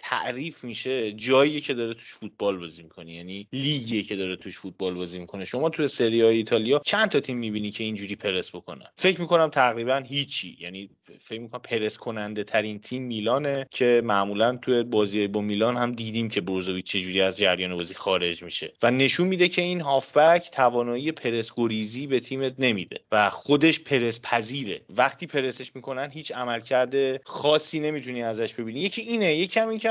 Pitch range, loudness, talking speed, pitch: 105-140 Hz, -25 LUFS, 175 wpm, 120 Hz